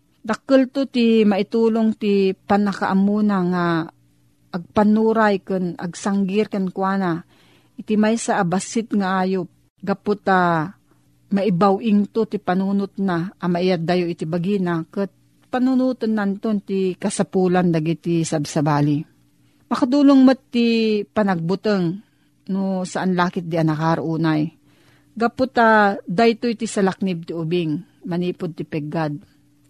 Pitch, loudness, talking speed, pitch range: 195 Hz, -20 LUFS, 105 wpm, 170-215 Hz